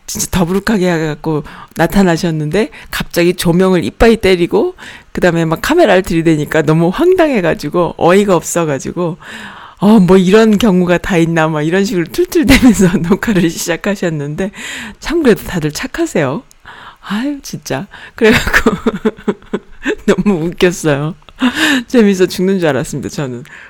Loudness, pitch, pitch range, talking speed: -12 LUFS, 185 Hz, 165-220 Hz, 315 characters per minute